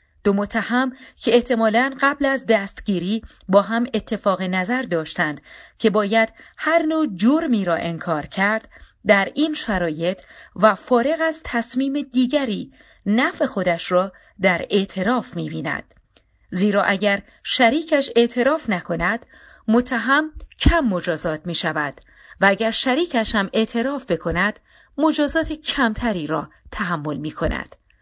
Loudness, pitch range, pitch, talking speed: -21 LUFS, 190-260 Hz, 225 Hz, 120 wpm